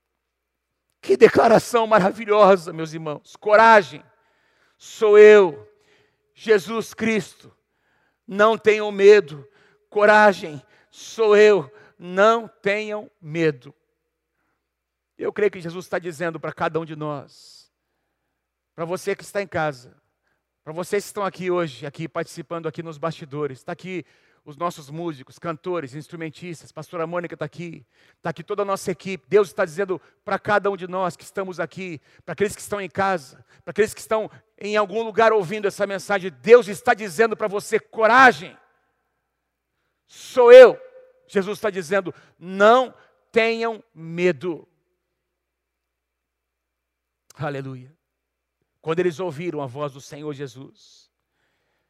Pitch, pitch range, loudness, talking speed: 180 Hz, 155-210 Hz, -19 LUFS, 130 wpm